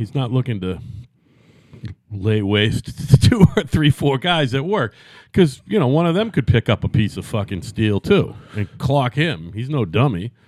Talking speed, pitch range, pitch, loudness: 200 wpm, 110-145 Hz, 125 Hz, -19 LUFS